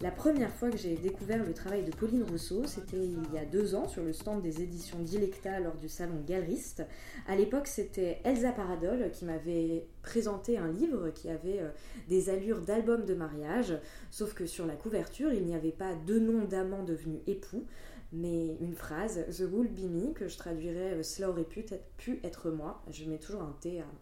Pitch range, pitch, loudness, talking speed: 165-210 Hz, 185 Hz, -35 LUFS, 200 wpm